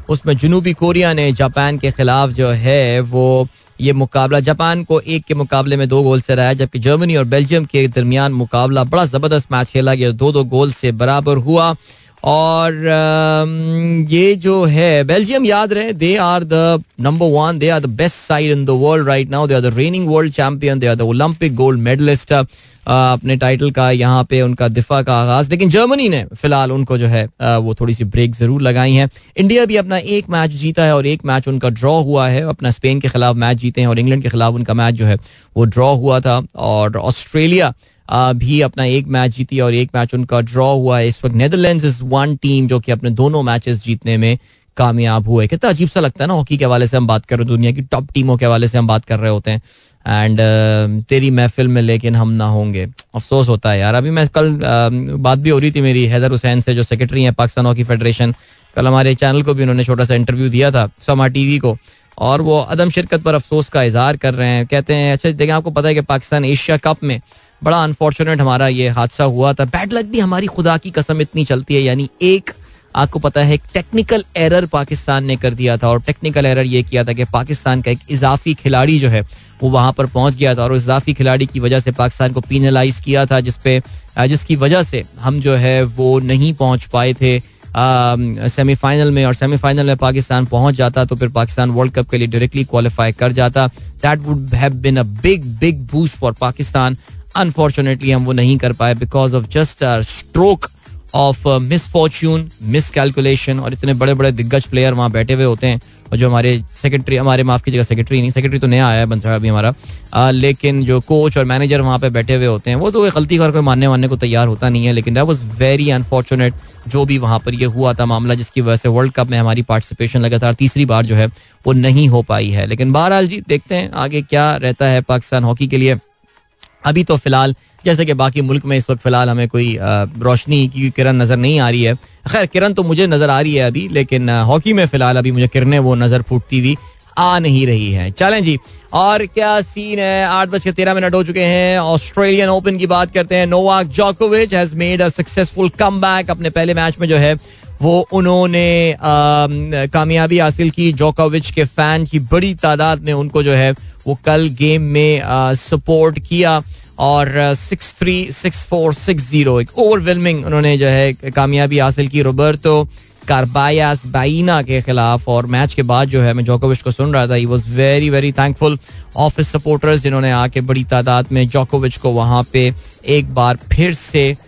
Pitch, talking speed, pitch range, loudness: 135 Hz, 210 wpm, 125-155 Hz, -13 LUFS